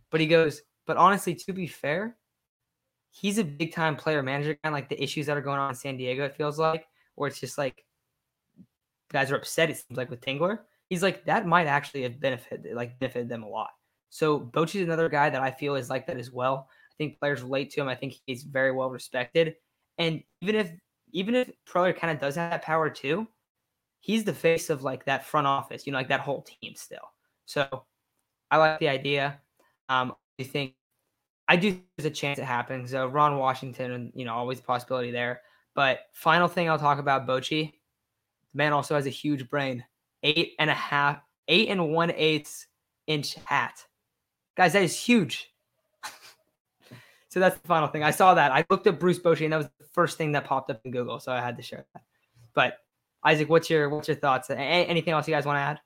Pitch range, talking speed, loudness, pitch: 130-165 Hz, 220 wpm, -27 LUFS, 145 Hz